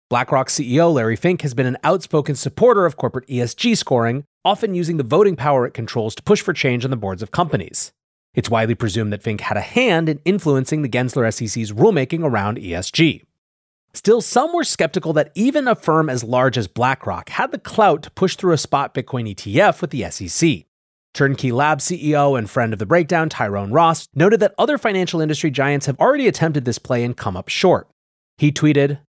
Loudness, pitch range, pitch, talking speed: -18 LUFS, 115-165 Hz, 140 Hz, 200 wpm